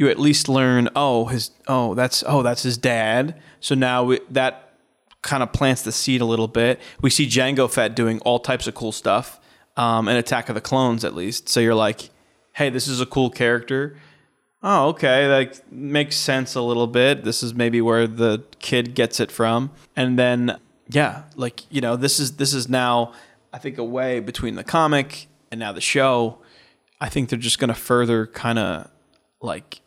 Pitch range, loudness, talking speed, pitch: 120-135 Hz, -20 LUFS, 195 wpm, 125 Hz